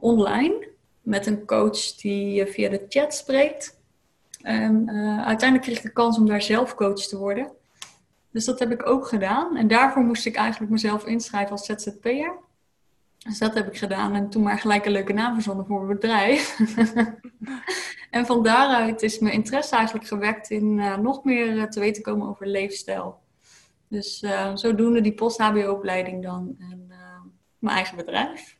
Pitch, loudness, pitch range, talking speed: 215 Hz, -23 LUFS, 205-235 Hz, 170 wpm